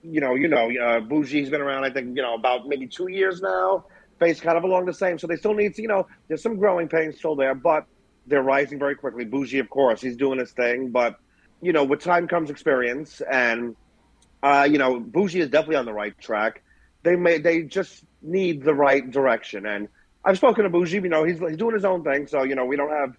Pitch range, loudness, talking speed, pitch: 135-180 Hz, -23 LUFS, 240 wpm, 150 Hz